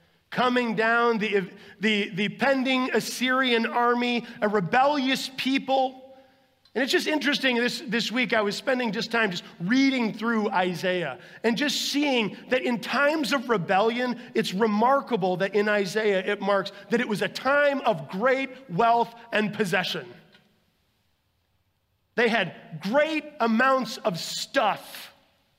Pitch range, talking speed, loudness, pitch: 205-260 Hz, 135 wpm, -25 LUFS, 230 Hz